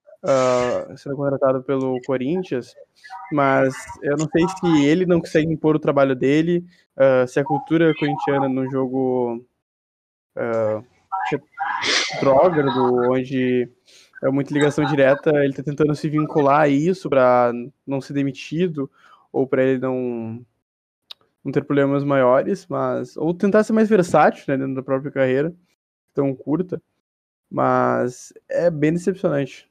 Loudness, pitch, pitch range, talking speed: -20 LUFS, 140 Hz, 130-155 Hz, 135 wpm